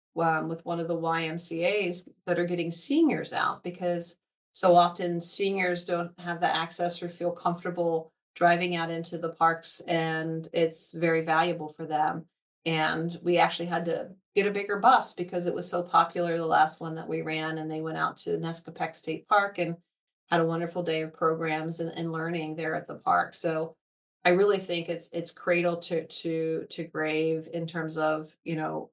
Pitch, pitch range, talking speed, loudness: 165 Hz, 160-175 Hz, 190 wpm, -28 LUFS